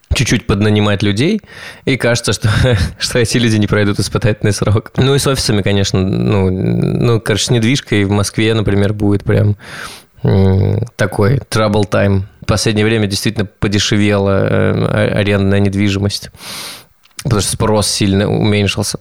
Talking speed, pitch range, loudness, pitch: 135 wpm, 100-115 Hz, -14 LUFS, 105 Hz